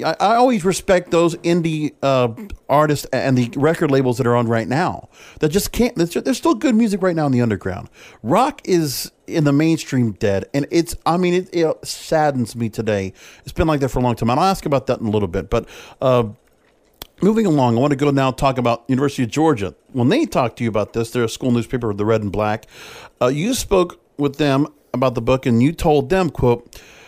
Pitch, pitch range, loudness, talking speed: 135 Hz, 120-165 Hz, -18 LUFS, 225 wpm